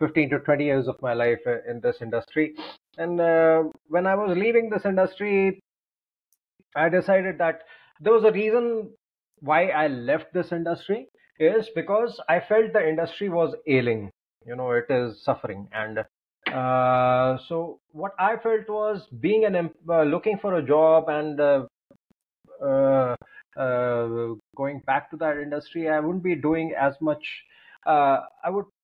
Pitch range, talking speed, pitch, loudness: 135-200 Hz, 155 wpm, 160 Hz, -24 LUFS